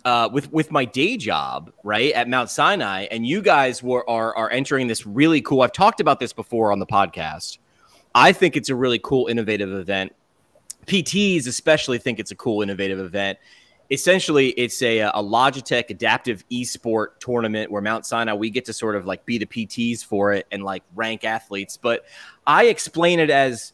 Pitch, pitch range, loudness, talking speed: 115 Hz, 105-135 Hz, -20 LUFS, 190 wpm